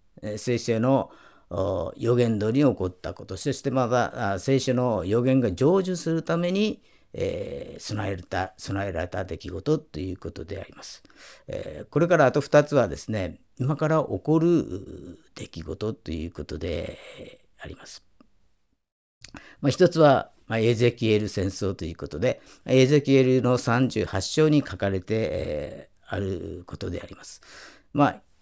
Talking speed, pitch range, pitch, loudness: 270 characters per minute, 95-140 Hz, 115 Hz, -25 LUFS